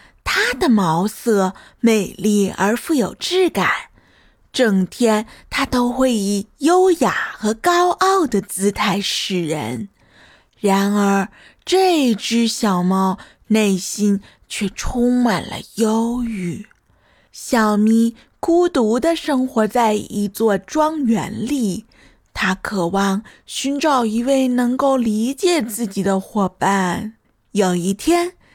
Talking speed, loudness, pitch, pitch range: 155 characters per minute, -18 LUFS, 220 Hz, 200-260 Hz